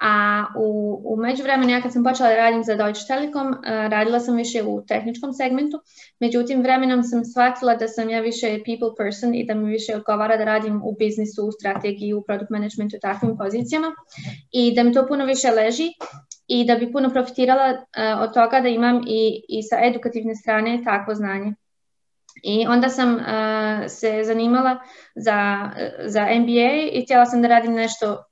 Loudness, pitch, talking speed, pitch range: -20 LUFS, 230 Hz, 180 wpm, 215-250 Hz